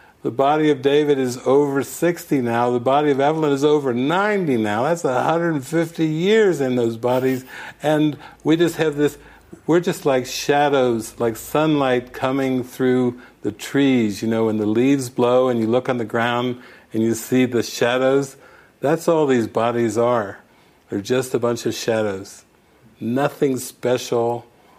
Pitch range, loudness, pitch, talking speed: 120-145 Hz, -20 LUFS, 130 Hz, 160 wpm